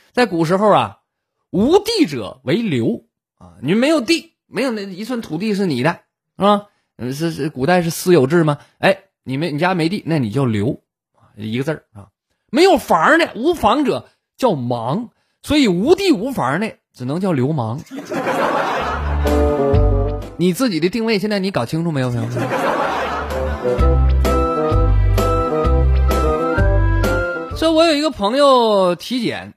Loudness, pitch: -17 LUFS, 165 Hz